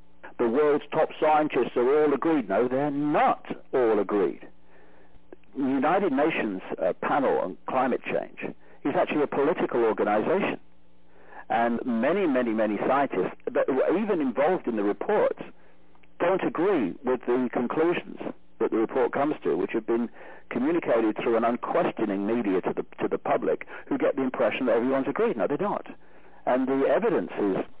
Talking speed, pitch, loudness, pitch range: 160 wpm, 120 Hz, -26 LUFS, 105-145 Hz